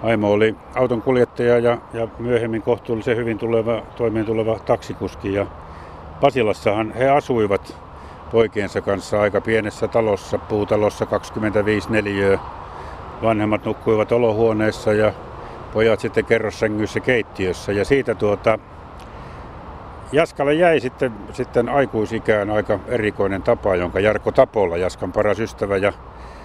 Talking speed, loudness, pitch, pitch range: 115 wpm, -20 LUFS, 110 Hz, 105-115 Hz